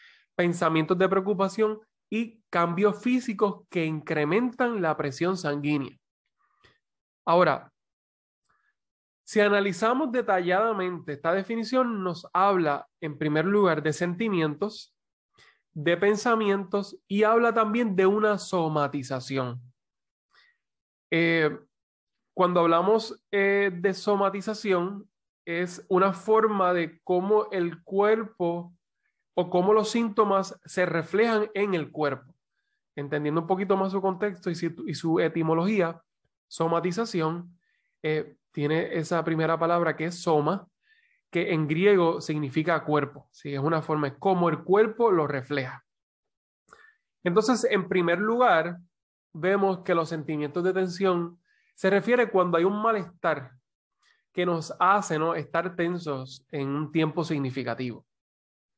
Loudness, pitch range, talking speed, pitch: -26 LUFS, 160-205 Hz, 115 wpm, 180 Hz